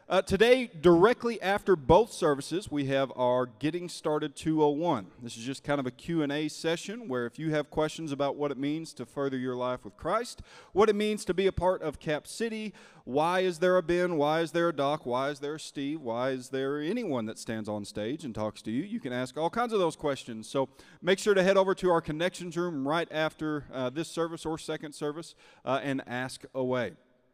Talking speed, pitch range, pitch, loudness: 225 wpm, 135-175 Hz, 155 Hz, -30 LUFS